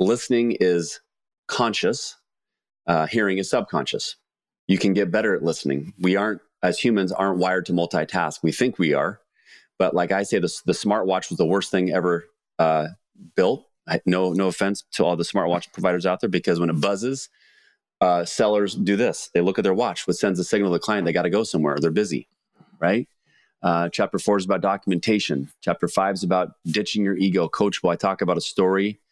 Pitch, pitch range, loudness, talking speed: 95 Hz, 85-100 Hz, -22 LUFS, 200 wpm